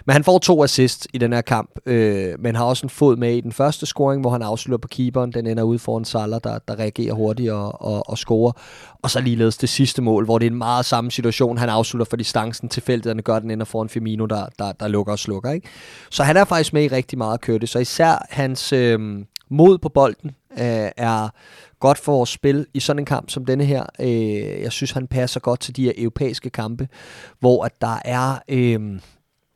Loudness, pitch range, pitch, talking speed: -20 LUFS, 115-135 Hz, 120 Hz, 240 wpm